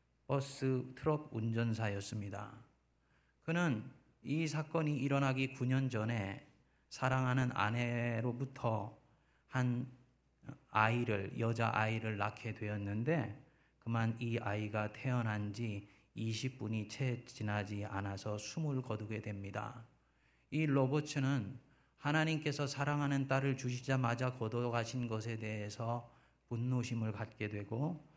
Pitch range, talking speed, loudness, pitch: 110-135 Hz, 245 characters per minute, -38 LUFS, 120 Hz